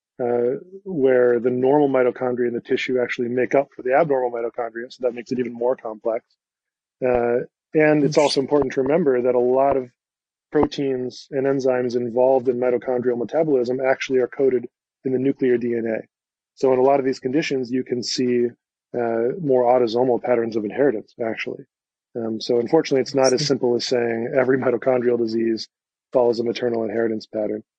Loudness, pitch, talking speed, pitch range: -21 LUFS, 125 Hz, 175 wpm, 120-135 Hz